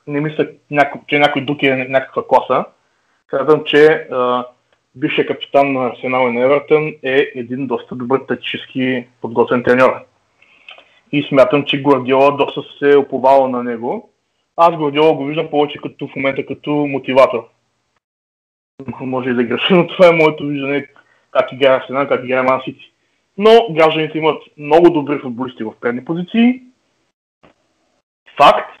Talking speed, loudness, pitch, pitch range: 140 wpm, -15 LUFS, 140 Hz, 130-150 Hz